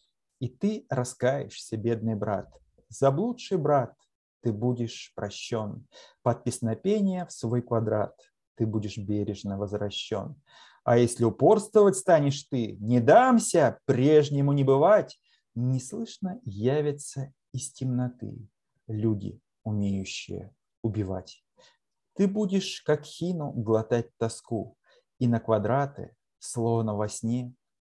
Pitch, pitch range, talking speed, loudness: 125 Hz, 110-150 Hz, 105 wpm, -27 LUFS